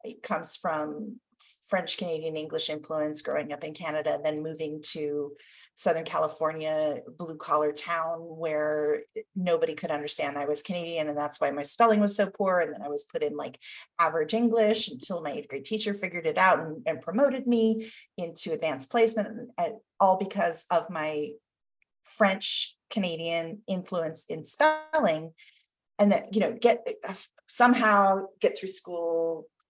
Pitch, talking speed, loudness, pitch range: 170 Hz, 160 wpm, -28 LUFS, 155-220 Hz